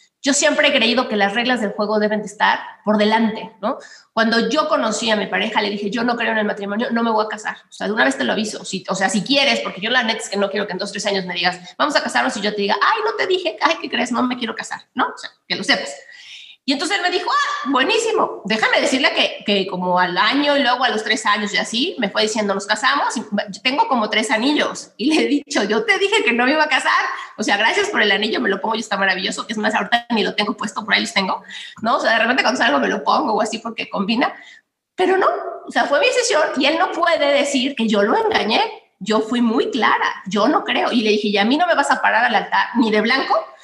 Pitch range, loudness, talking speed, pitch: 210-290 Hz, -18 LUFS, 280 wpm, 230 Hz